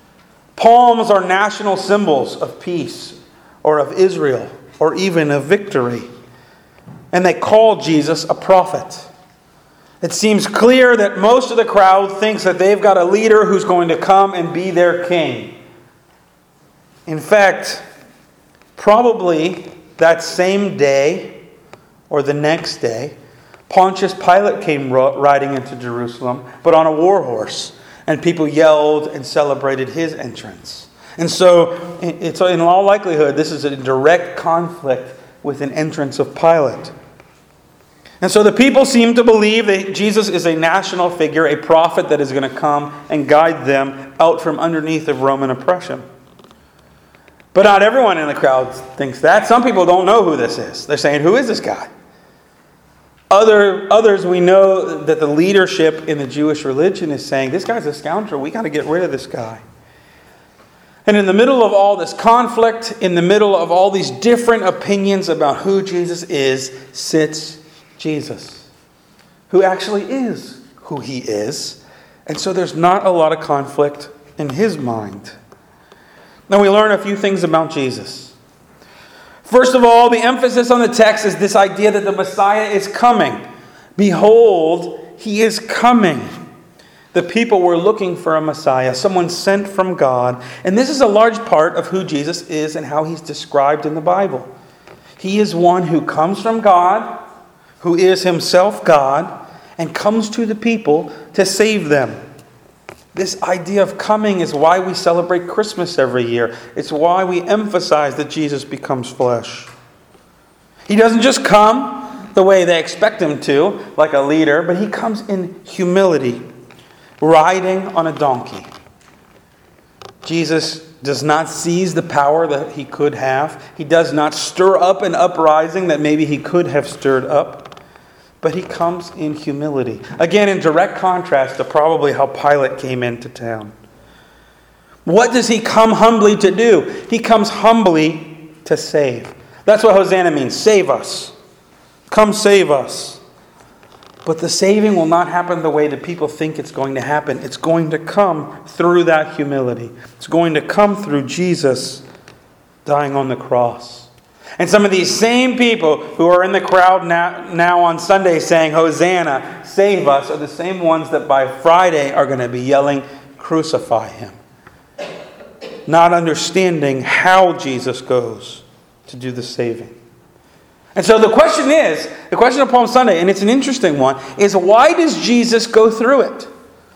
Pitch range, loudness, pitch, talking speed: 145-195 Hz, -14 LUFS, 170 Hz, 160 wpm